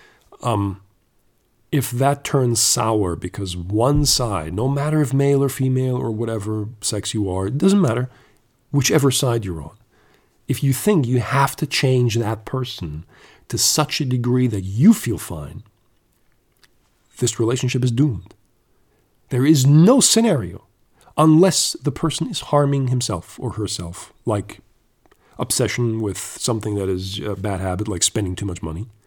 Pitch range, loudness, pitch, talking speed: 105-140 Hz, -19 LUFS, 120 Hz, 150 wpm